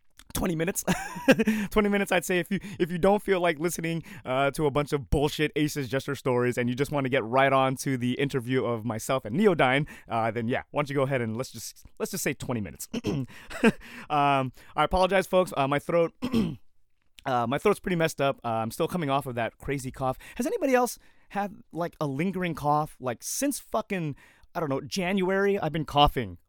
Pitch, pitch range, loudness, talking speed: 145 Hz, 130-185 Hz, -27 LUFS, 215 wpm